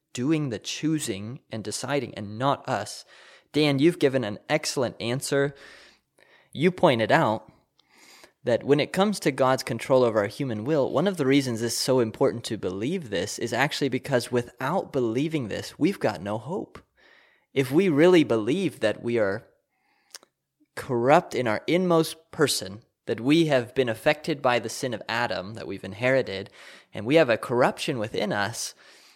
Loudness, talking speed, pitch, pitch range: -25 LUFS, 165 wpm, 135 Hz, 120-155 Hz